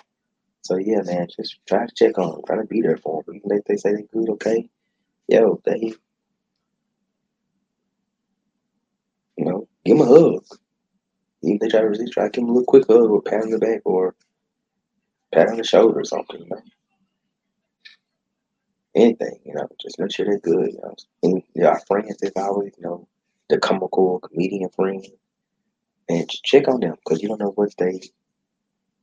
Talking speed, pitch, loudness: 190 wpm, 210 Hz, -20 LUFS